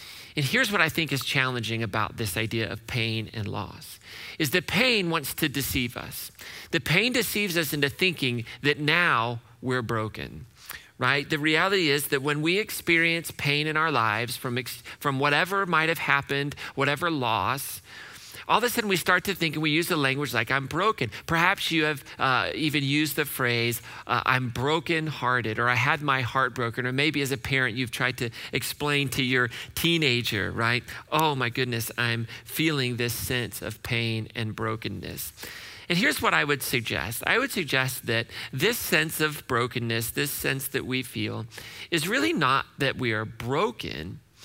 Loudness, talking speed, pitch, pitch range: -25 LUFS, 180 wpm, 130 Hz, 115-155 Hz